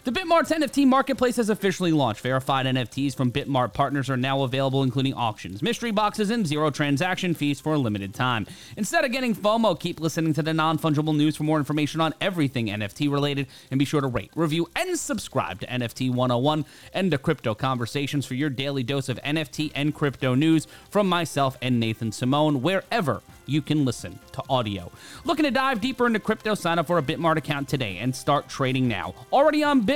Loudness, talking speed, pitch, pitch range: -24 LUFS, 200 wpm, 150 Hz, 130-175 Hz